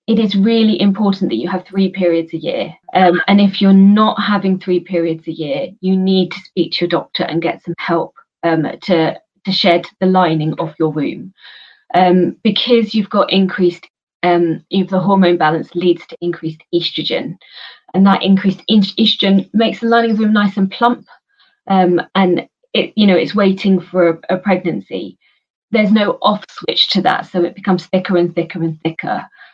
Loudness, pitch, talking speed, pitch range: -14 LUFS, 185 Hz, 190 wpm, 175-200 Hz